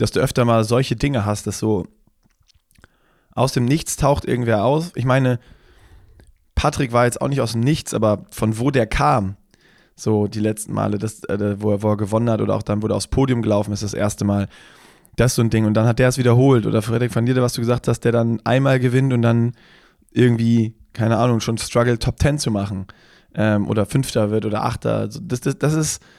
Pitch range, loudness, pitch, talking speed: 105-125 Hz, -19 LUFS, 115 Hz, 220 wpm